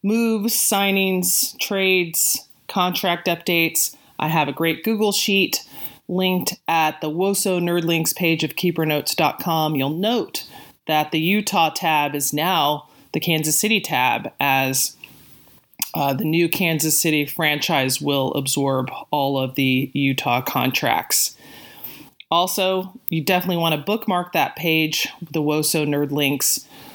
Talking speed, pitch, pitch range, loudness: 130 wpm, 165 Hz, 150-185 Hz, -20 LUFS